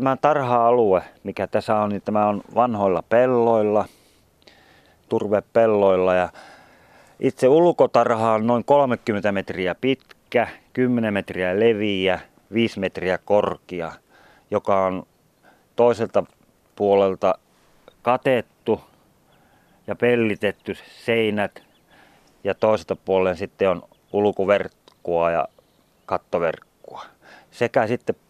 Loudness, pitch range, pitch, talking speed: -21 LUFS, 95-115 Hz, 105 Hz, 90 wpm